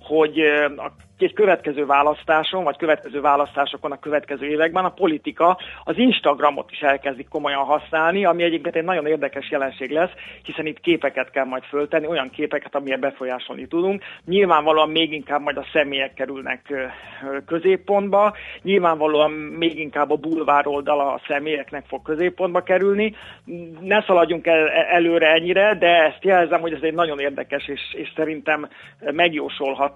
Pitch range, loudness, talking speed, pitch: 145-170 Hz, -20 LUFS, 140 wpm, 155 Hz